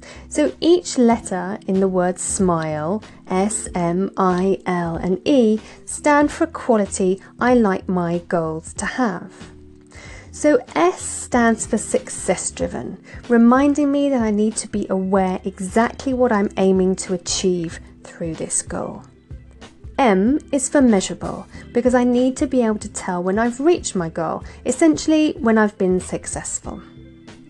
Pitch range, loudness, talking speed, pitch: 185-250 Hz, -19 LUFS, 150 wpm, 200 Hz